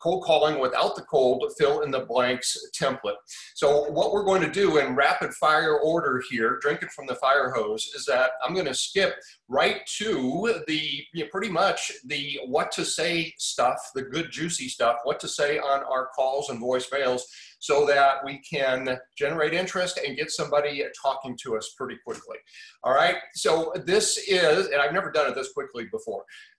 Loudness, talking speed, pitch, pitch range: -25 LUFS, 190 wpm, 155 Hz, 140-205 Hz